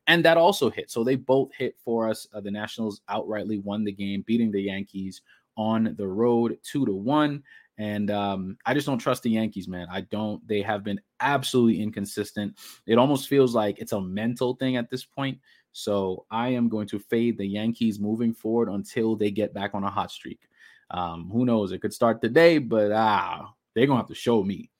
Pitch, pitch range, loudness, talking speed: 110 Hz, 100-120 Hz, -26 LUFS, 210 wpm